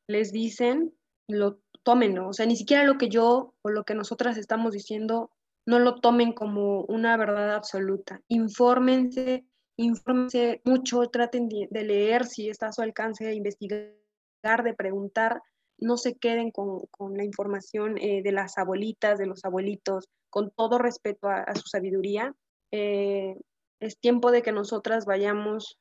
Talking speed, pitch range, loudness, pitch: 155 wpm, 205-240 Hz, -26 LUFS, 220 Hz